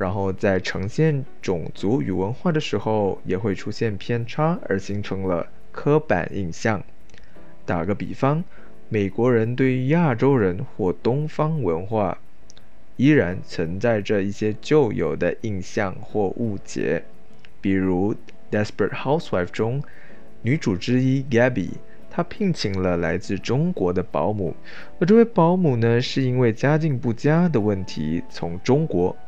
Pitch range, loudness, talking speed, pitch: 95-145 Hz, -22 LUFS, 245 characters per minute, 115 Hz